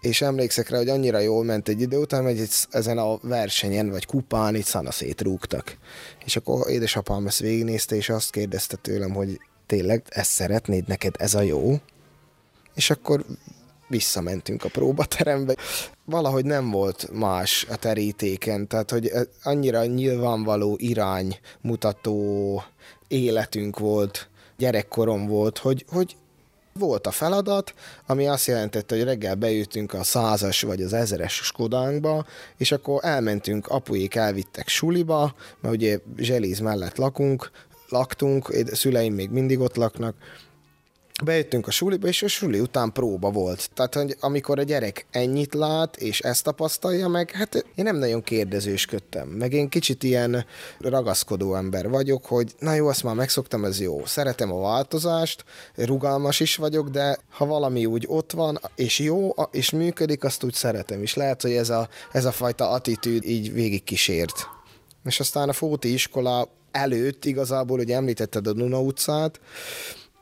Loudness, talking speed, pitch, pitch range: -24 LUFS, 150 wpm, 120 Hz, 105-140 Hz